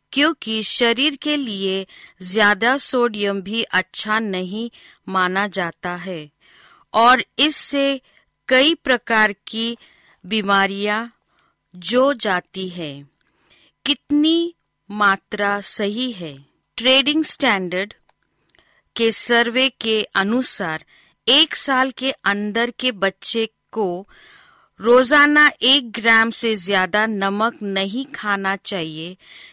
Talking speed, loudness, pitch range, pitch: 95 wpm, -18 LUFS, 195-255 Hz, 220 Hz